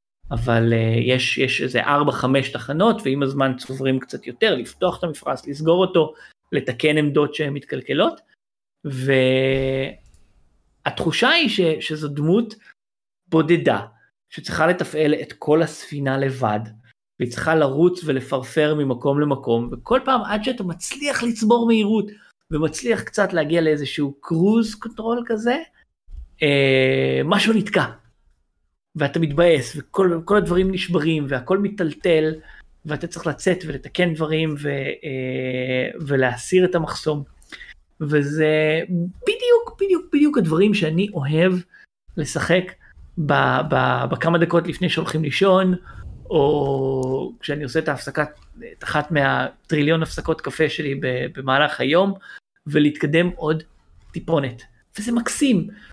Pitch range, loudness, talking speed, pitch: 135-180 Hz, -20 LUFS, 110 wpm, 155 Hz